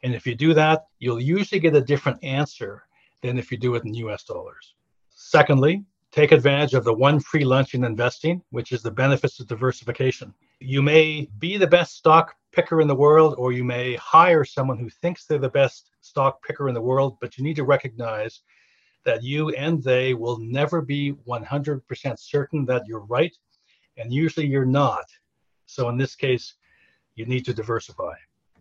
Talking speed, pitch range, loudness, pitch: 185 wpm, 125-150 Hz, -21 LUFS, 135 Hz